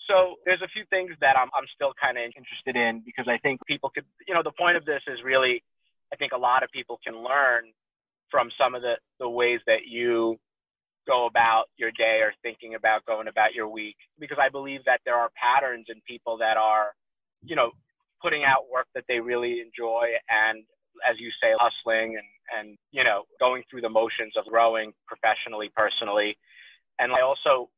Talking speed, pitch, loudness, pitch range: 200 wpm, 115 Hz, -25 LUFS, 110-130 Hz